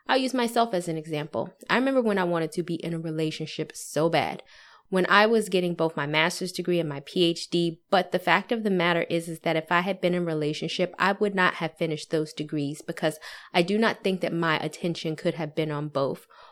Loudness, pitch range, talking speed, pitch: -26 LUFS, 160-185 Hz, 235 wpm, 170 Hz